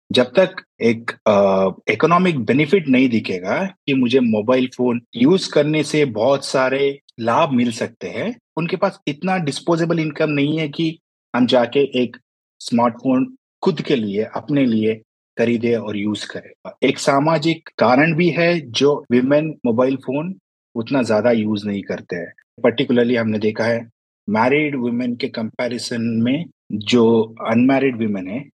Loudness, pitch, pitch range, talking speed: -18 LUFS, 130 Hz, 115-155 Hz, 145 wpm